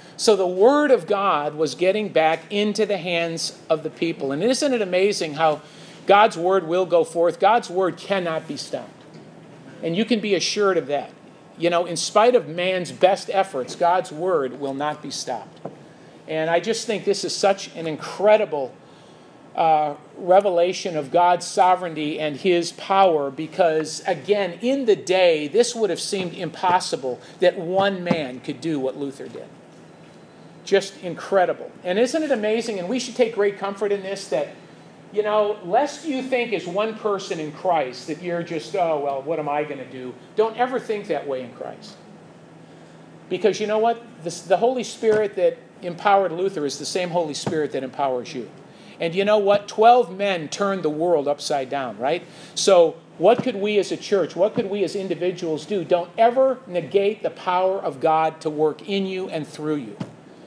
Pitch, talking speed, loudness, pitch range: 180 Hz, 185 wpm, -22 LUFS, 160-205 Hz